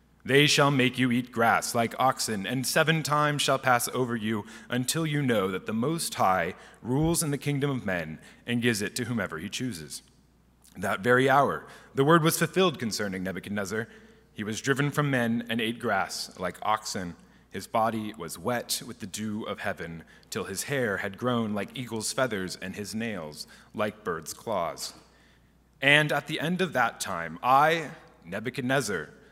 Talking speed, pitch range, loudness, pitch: 175 wpm, 105-140 Hz, -27 LUFS, 120 Hz